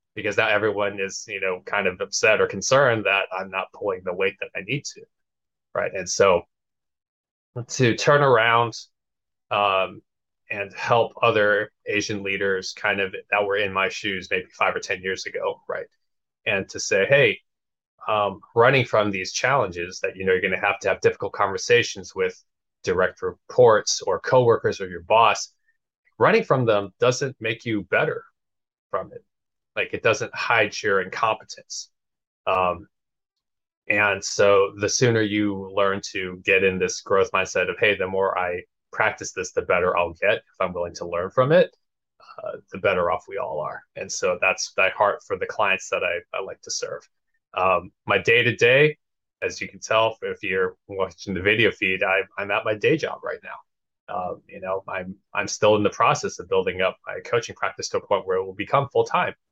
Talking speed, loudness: 190 wpm, -22 LUFS